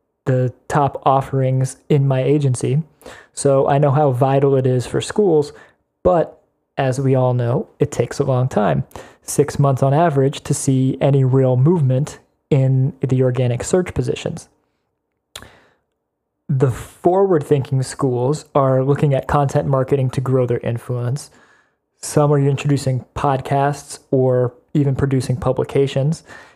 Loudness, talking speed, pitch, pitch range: -18 LUFS, 135 wpm, 135 Hz, 130-145 Hz